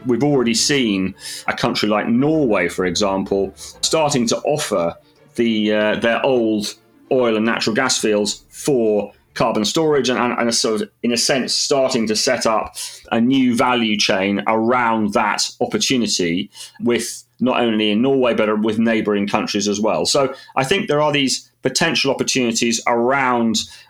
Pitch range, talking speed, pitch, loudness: 105-125 Hz, 160 wpm, 115 Hz, -18 LUFS